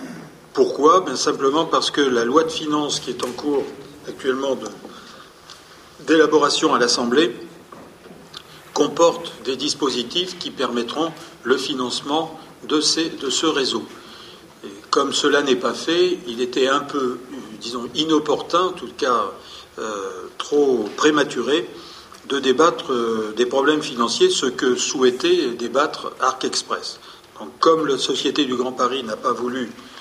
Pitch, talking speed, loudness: 160 Hz, 140 wpm, -20 LUFS